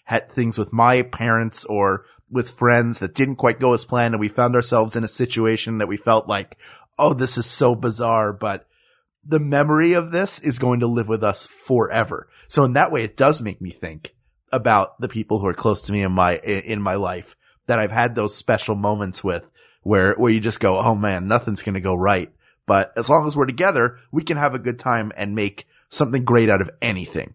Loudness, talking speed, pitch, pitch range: -20 LUFS, 225 wpm, 115 Hz, 105-125 Hz